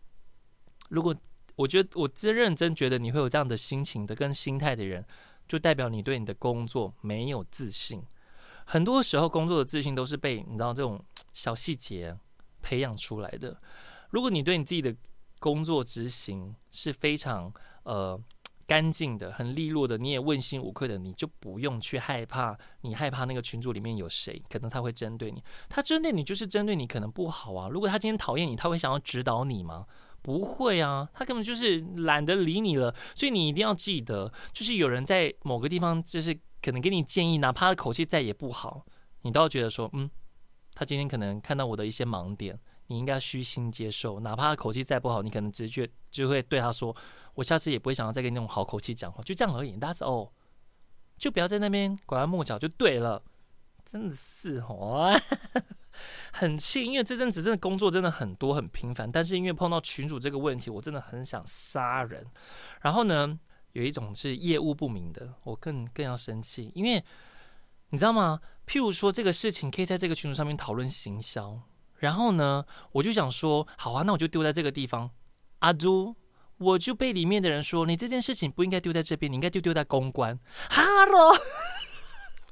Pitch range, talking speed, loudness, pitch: 120-170 Hz, 305 characters per minute, -29 LUFS, 140 Hz